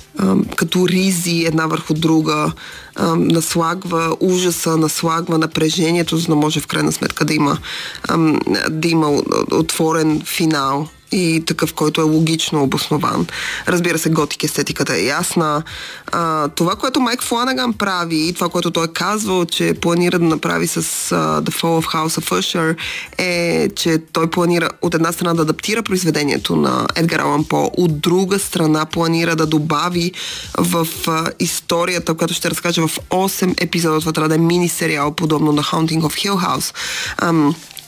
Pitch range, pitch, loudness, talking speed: 155-175 Hz, 165 Hz, -17 LUFS, 150 wpm